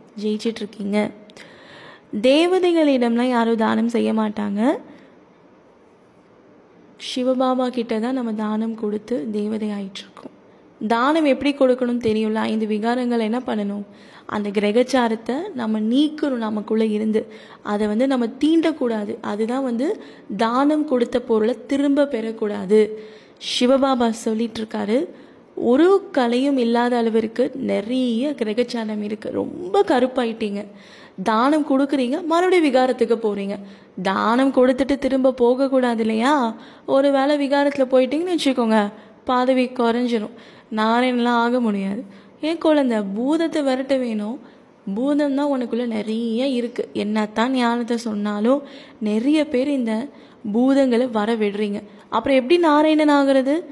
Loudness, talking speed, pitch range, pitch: -20 LUFS, 105 wpm, 220-270 Hz, 240 Hz